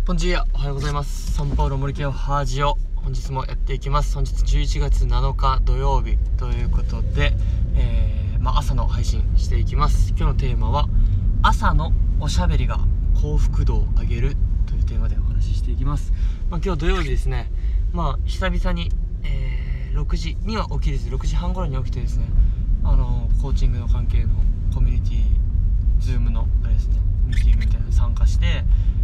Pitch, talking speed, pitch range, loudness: 90 Hz, 370 characters per minute, 80-105 Hz, -23 LUFS